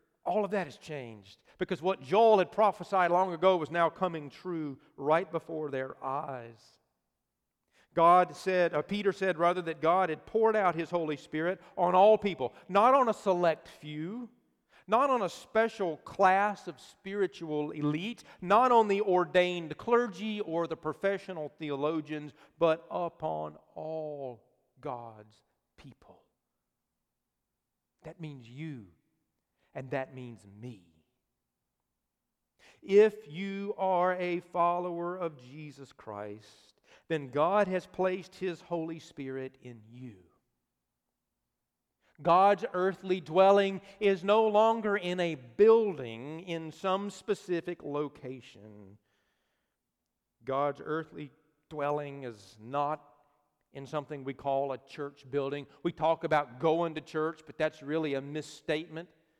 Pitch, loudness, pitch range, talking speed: 160 Hz, -30 LUFS, 140-185 Hz, 125 wpm